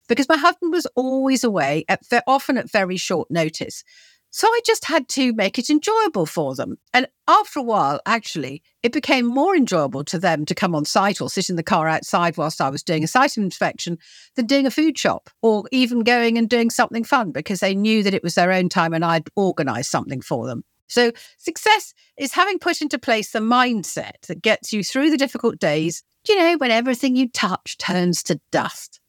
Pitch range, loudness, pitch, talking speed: 175-275 Hz, -20 LUFS, 230 Hz, 210 wpm